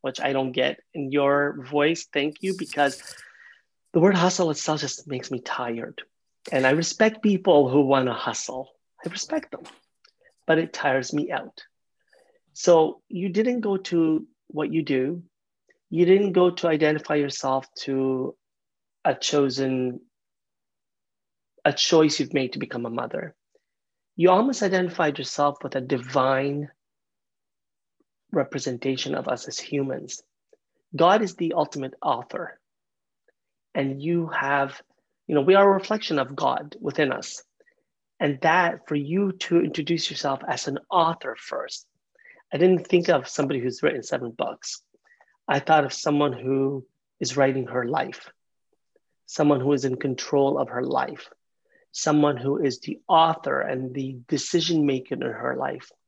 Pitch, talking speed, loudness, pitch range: 150 Hz, 150 wpm, -24 LUFS, 135-175 Hz